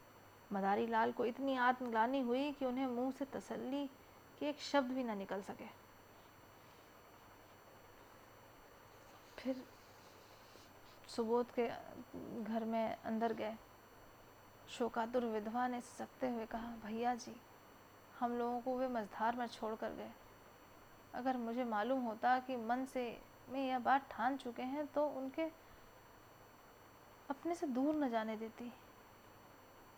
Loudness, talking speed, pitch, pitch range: -40 LUFS, 125 wpm, 240 Hz, 220-260 Hz